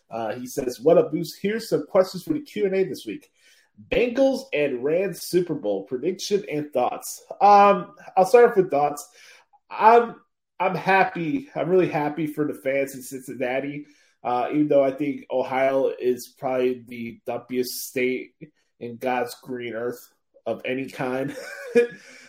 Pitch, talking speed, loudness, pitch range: 145 Hz, 160 wpm, -23 LUFS, 125-190 Hz